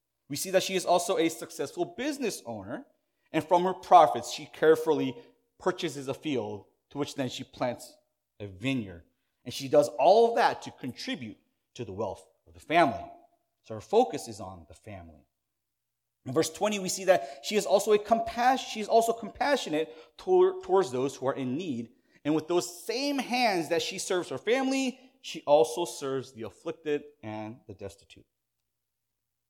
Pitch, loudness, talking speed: 160 Hz, -28 LUFS, 175 wpm